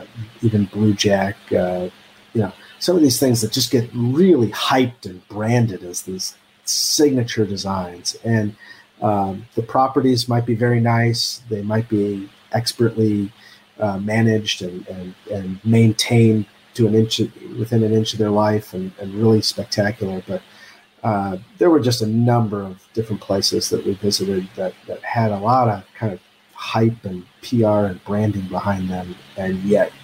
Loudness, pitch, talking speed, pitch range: -19 LUFS, 110 Hz, 165 wpm, 100-115 Hz